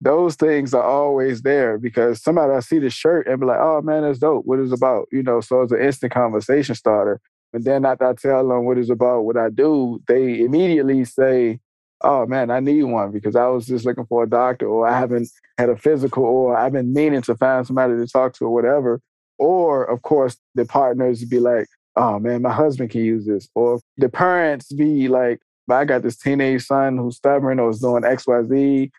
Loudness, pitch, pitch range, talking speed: -18 LUFS, 125 Hz, 120-135 Hz, 220 wpm